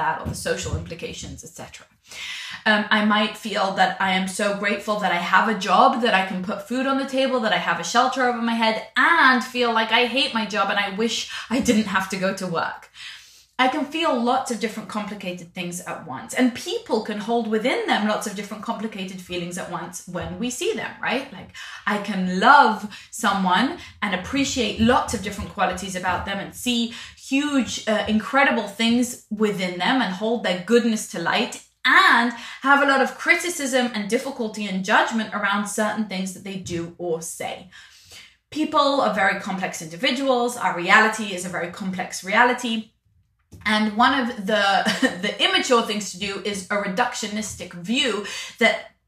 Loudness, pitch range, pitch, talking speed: -21 LUFS, 195-245 Hz, 215 Hz, 185 wpm